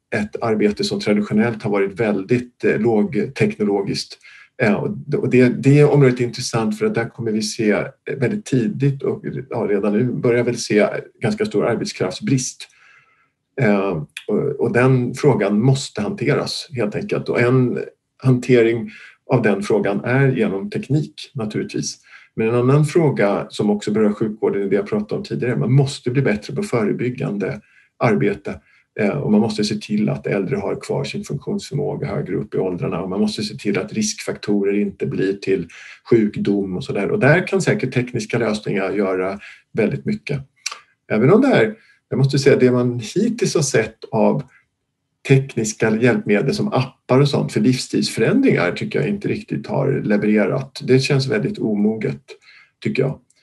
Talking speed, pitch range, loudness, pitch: 155 wpm, 110-140 Hz, -19 LUFS, 125 Hz